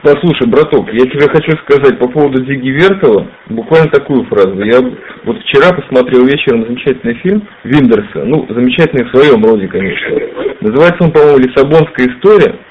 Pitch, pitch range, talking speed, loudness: 145 Hz, 125-190 Hz, 155 wpm, -9 LUFS